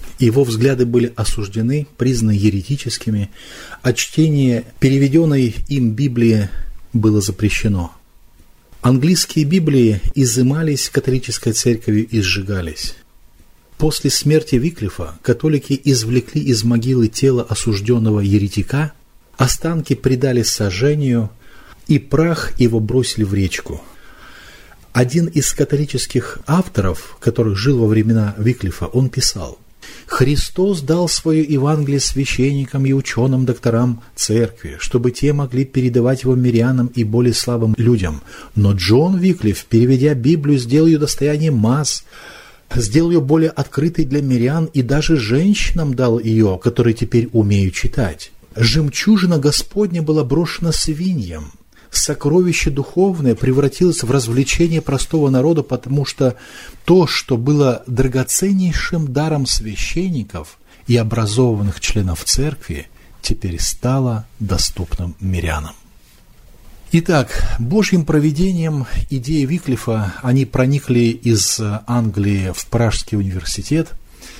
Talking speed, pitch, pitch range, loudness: 105 wpm, 125 Hz, 110-145 Hz, -16 LUFS